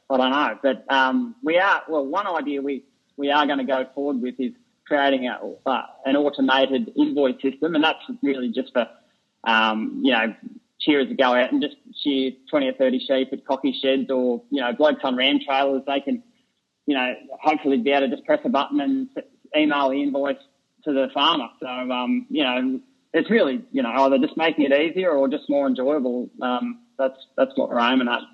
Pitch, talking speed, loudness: 140 Hz, 210 wpm, -22 LUFS